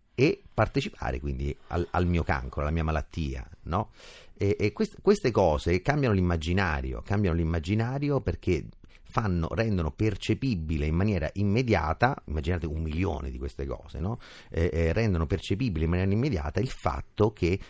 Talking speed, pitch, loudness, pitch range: 150 wpm, 90 Hz, -28 LUFS, 80-105 Hz